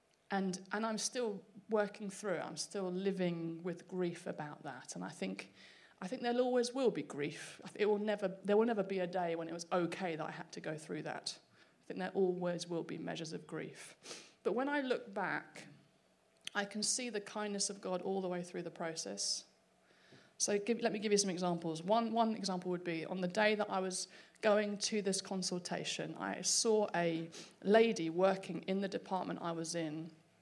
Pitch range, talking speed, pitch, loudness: 175-210 Hz, 205 wpm, 190 Hz, -37 LUFS